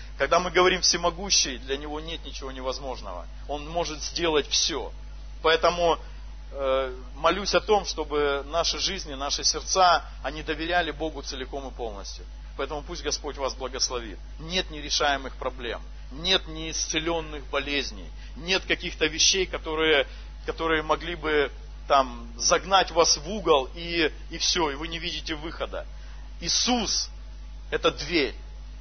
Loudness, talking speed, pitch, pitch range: -25 LUFS, 130 wpm, 155 Hz, 135-170 Hz